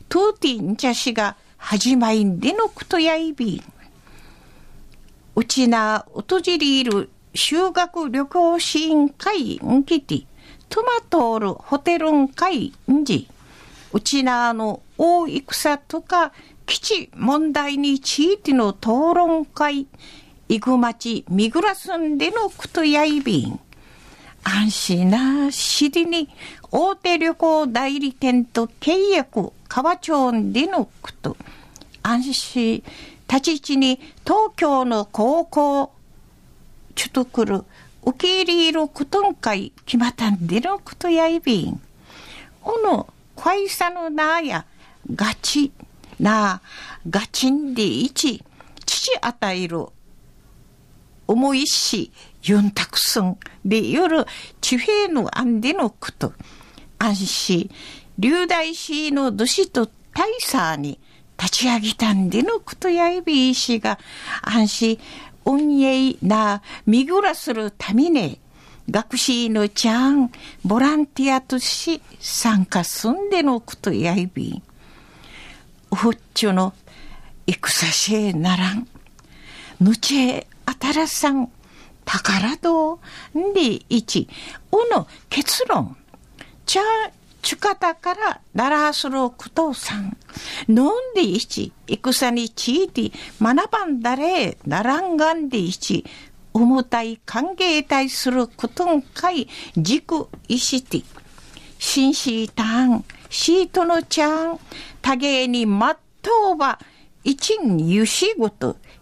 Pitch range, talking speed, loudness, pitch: 225-330 Hz, 205 characters per minute, -20 LUFS, 270 Hz